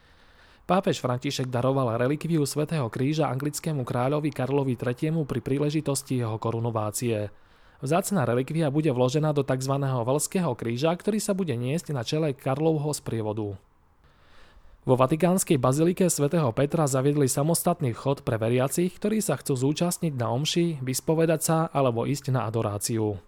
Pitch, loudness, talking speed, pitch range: 140 Hz, -26 LUFS, 135 wpm, 120-160 Hz